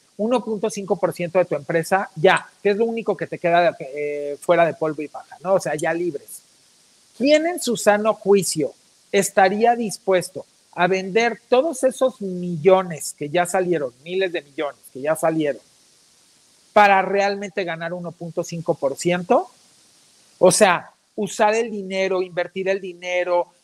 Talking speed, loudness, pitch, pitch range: 145 wpm, -21 LUFS, 185 Hz, 170-205 Hz